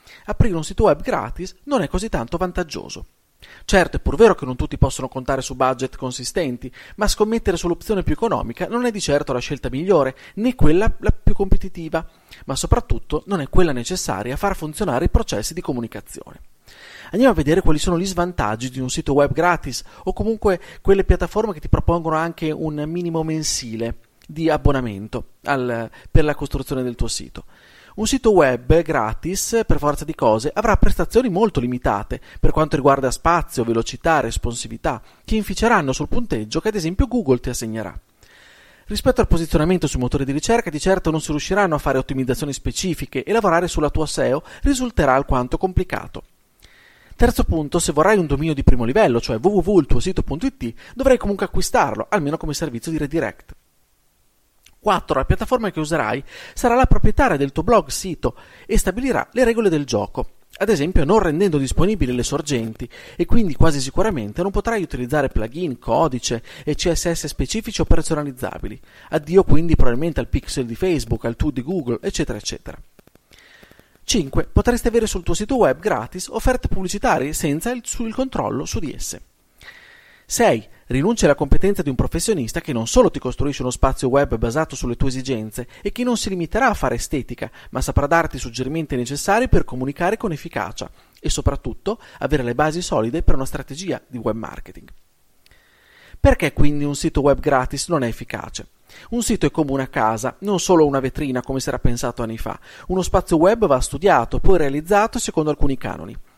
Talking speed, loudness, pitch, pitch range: 175 wpm, -20 LUFS, 155 Hz, 130-190 Hz